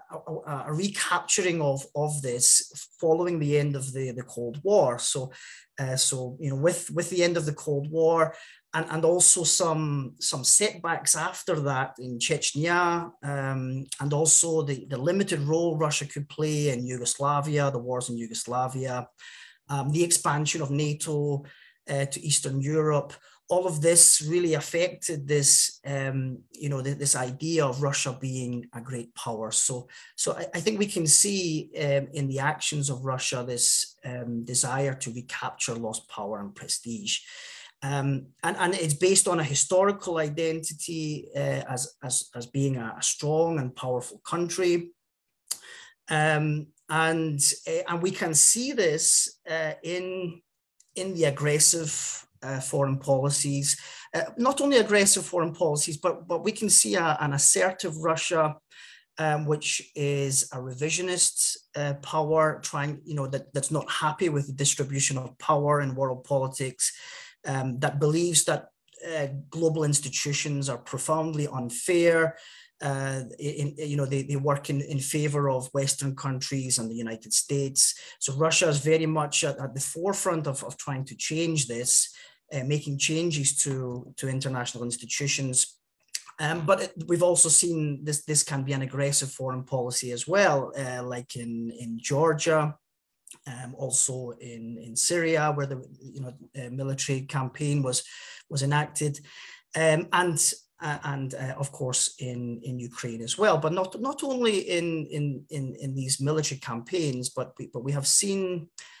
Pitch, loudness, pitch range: 145 Hz, -25 LUFS, 135-165 Hz